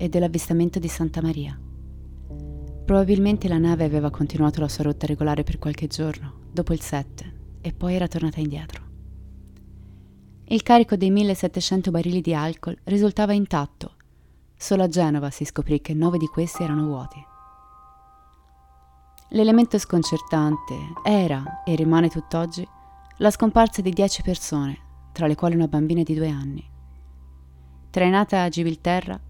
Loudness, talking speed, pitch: -22 LUFS, 135 wpm, 155 Hz